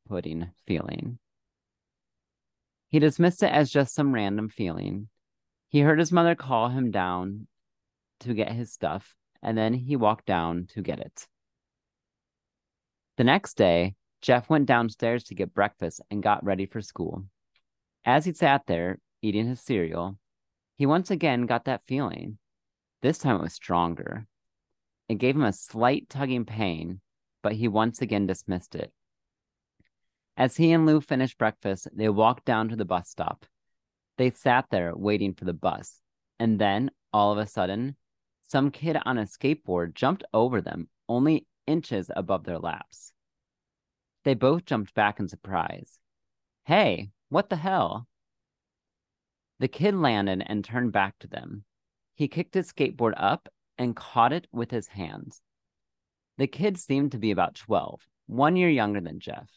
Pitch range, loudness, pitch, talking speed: 95-135 Hz, -26 LUFS, 110 Hz, 155 wpm